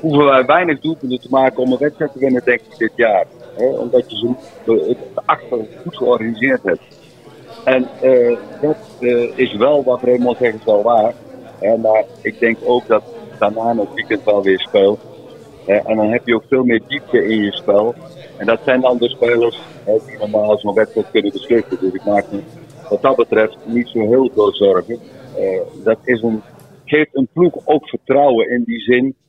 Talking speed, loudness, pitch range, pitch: 195 wpm, -16 LUFS, 115-135 Hz, 125 Hz